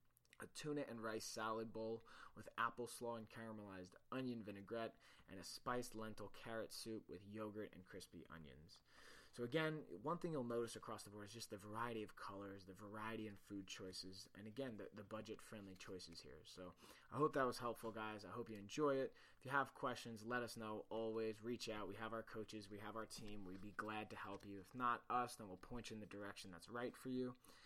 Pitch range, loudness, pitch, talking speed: 100-120 Hz, -49 LUFS, 110 Hz, 220 wpm